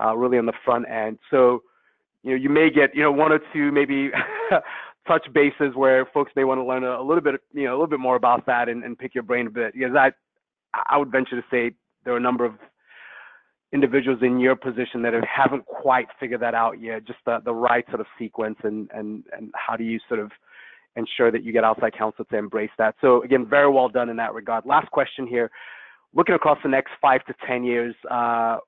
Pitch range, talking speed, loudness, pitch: 115-135 Hz, 240 wpm, -22 LUFS, 125 Hz